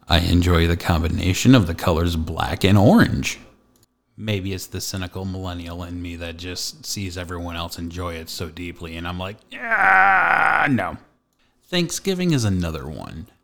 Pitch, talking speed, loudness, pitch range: 90 Hz, 155 wpm, -20 LUFS, 85-100 Hz